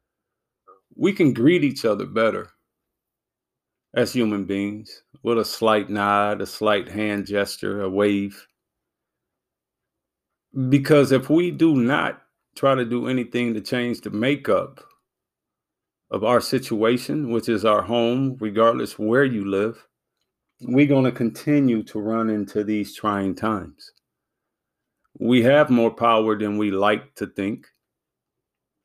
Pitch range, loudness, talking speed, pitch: 105-125 Hz, -21 LUFS, 130 wpm, 110 Hz